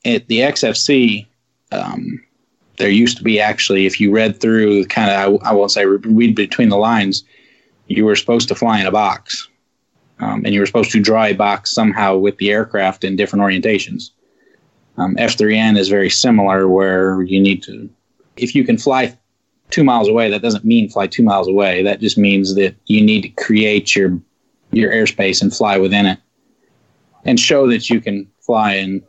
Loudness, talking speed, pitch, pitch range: -14 LUFS, 190 wpm, 100 Hz, 95-110 Hz